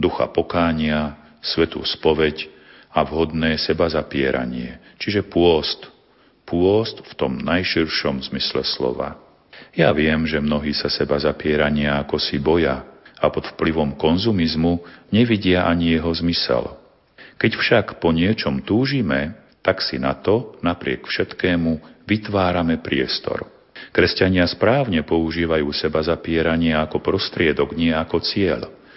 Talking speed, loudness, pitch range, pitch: 120 wpm, -20 LUFS, 75-85 Hz, 80 Hz